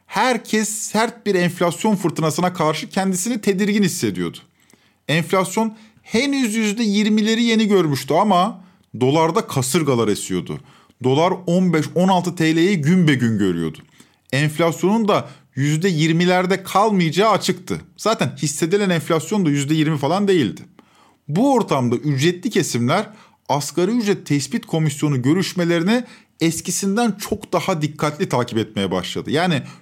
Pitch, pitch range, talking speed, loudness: 175 Hz, 150-205 Hz, 110 wpm, -19 LUFS